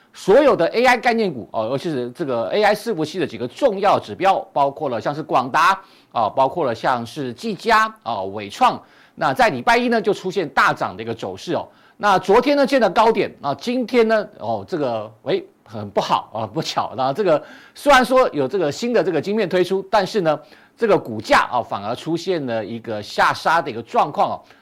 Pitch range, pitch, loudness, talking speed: 140-230 Hz, 190 Hz, -19 LUFS, 310 characters per minute